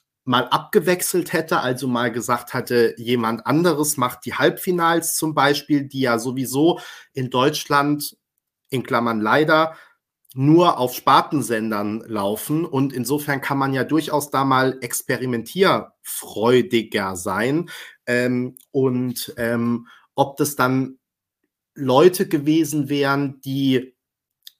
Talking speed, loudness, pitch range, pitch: 110 wpm, -20 LUFS, 120-150 Hz, 130 Hz